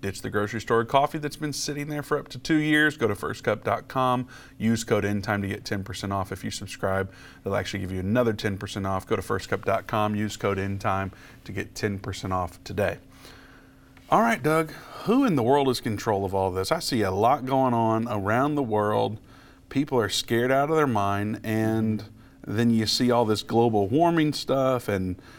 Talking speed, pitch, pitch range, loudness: 205 wpm, 110 Hz, 100-130 Hz, -25 LUFS